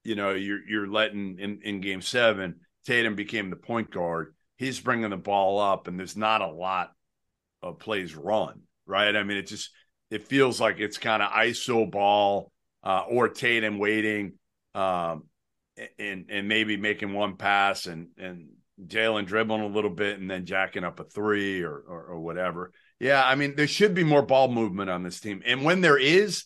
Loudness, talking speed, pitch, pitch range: -26 LUFS, 190 wpm, 105 Hz, 95-115 Hz